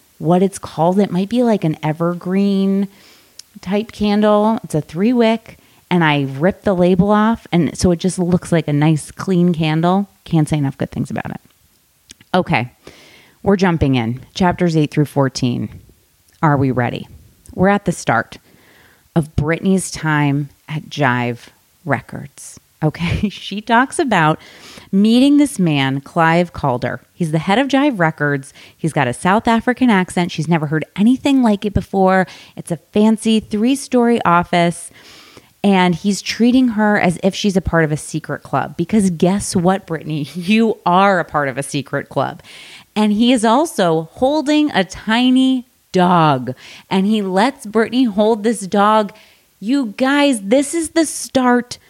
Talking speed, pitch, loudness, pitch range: 160 wpm, 185 Hz, -16 LUFS, 155-215 Hz